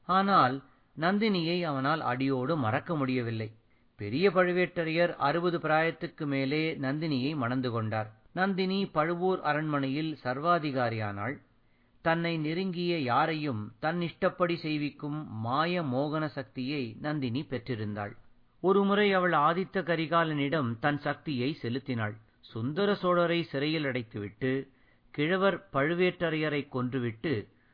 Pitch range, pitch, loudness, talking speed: 130-170 Hz, 150 Hz, -30 LUFS, 95 wpm